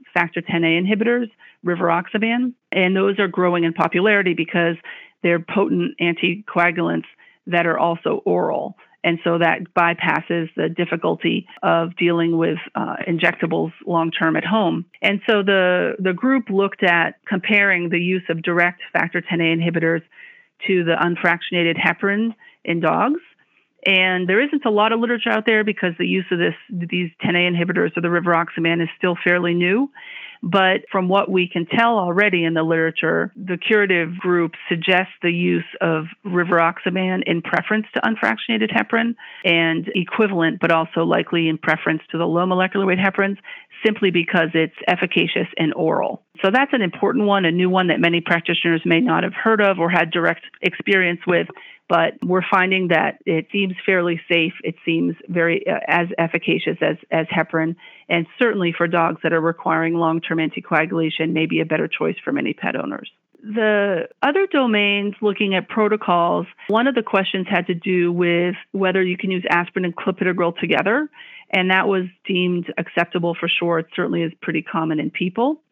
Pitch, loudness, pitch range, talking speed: 180 Hz, -19 LUFS, 170-200 Hz, 170 wpm